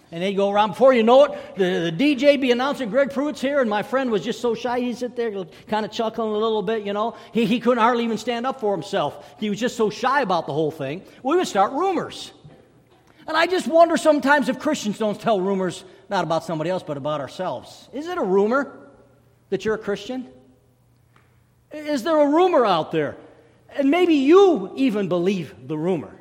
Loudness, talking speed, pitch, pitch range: -21 LUFS, 215 wpm, 225 Hz, 185-275 Hz